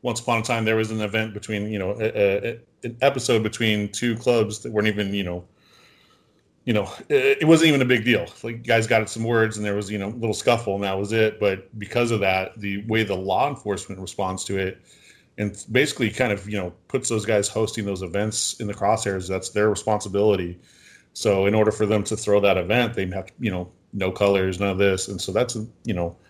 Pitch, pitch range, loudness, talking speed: 105 Hz, 100-115 Hz, -23 LUFS, 235 wpm